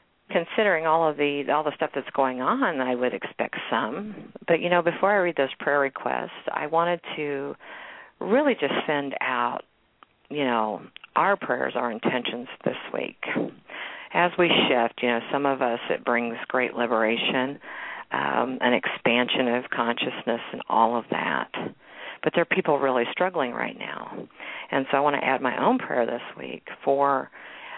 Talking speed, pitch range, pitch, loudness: 170 wpm, 125-160 Hz, 140 Hz, -25 LUFS